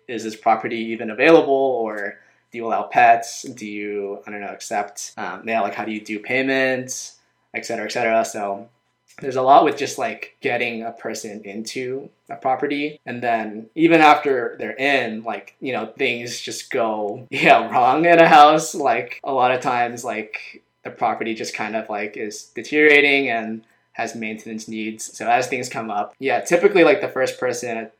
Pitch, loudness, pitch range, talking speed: 115 Hz, -19 LUFS, 110-135 Hz, 185 wpm